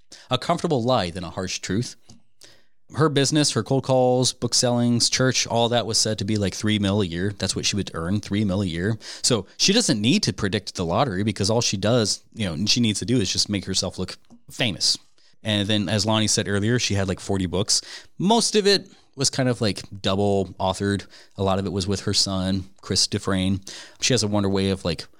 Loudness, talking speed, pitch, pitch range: -22 LUFS, 225 wpm, 105 Hz, 95-120 Hz